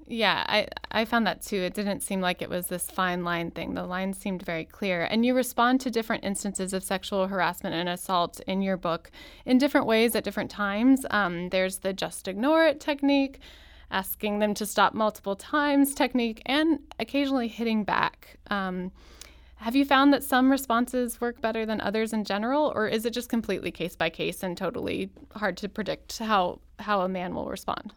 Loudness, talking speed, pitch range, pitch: -27 LUFS, 195 wpm, 190-250 Hz, 210 Hz